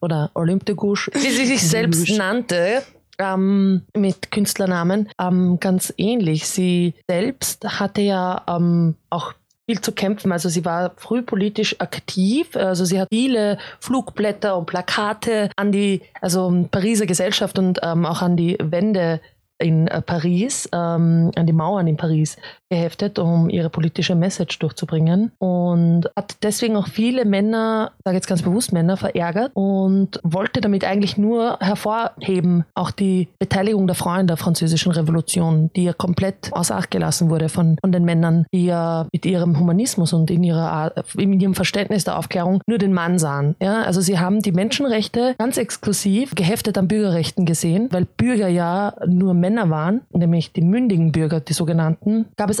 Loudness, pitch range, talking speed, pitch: -19 LUFS, 170-205 Hz, 160 wpm, 185 Hz